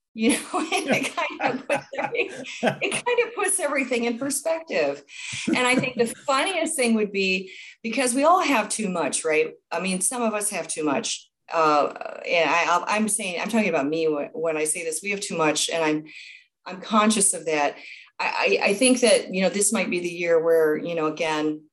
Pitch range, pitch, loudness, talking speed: 165-270 Hz, 210 Hz, -23 LUFS, 210 wpm